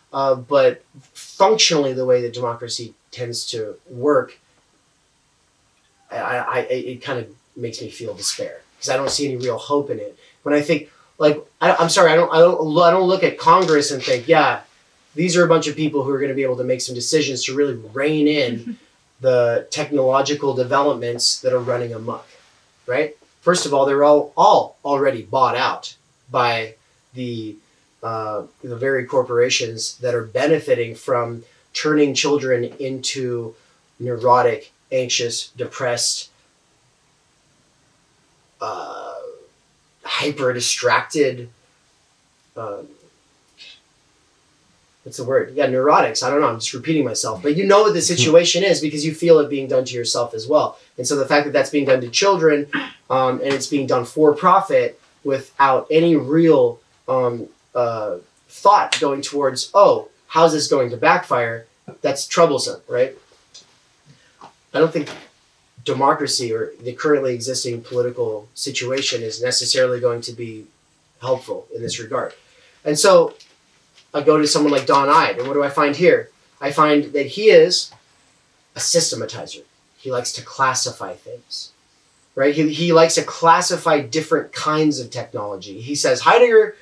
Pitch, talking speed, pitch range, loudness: 145 Hz, 155 wpm, 130-175 Hz, -18 LUFS